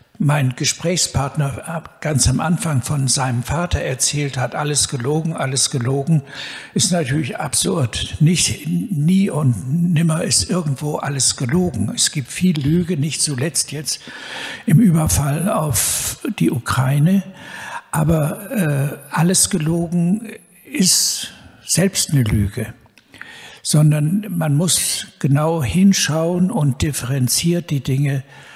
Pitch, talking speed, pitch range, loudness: 150 Hz, 115 wpm, 135-175 Hz, -18 LUFS